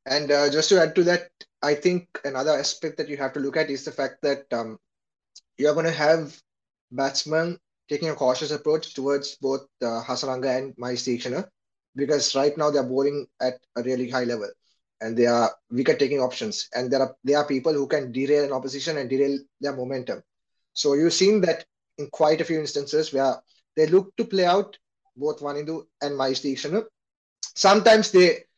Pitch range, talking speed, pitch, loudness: 135-160 Hz, 185 wpm, 145 Hz, -24 LUFS